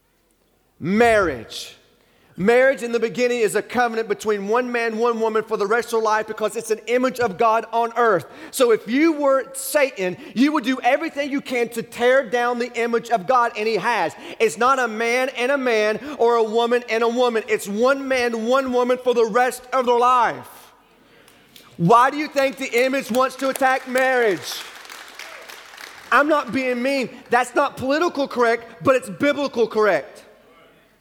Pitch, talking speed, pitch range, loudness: 245 Hz, 180 wpm, 230-265 Hz, -20 LUFS